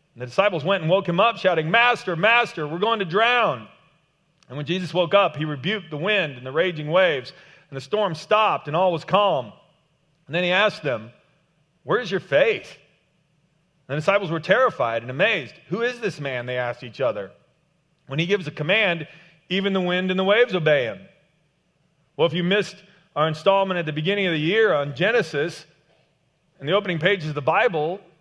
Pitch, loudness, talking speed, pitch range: 170 Hz, -22 LUFS, 200 wpm, 155-195 Hz